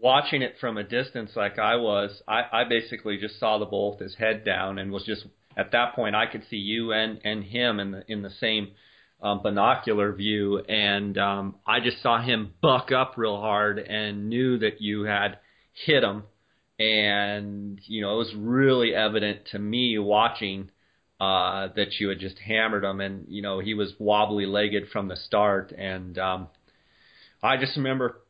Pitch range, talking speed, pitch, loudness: 100-115 Hz, 190 wpm, 105 Hz, -25 LUFS